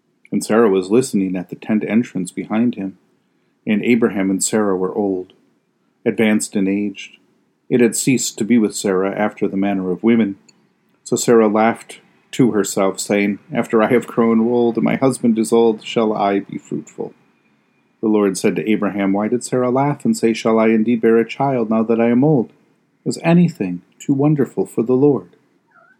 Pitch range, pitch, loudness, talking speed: 100-120 Hz, 110 Hz, -17 LUFS, 185 wpm